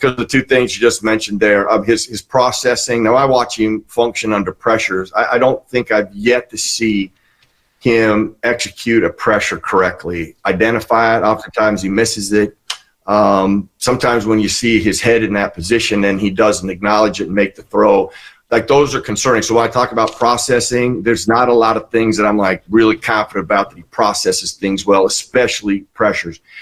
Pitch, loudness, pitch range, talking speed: 110 Hz, -14 LUFS, 105-120 Hz, 195 wpm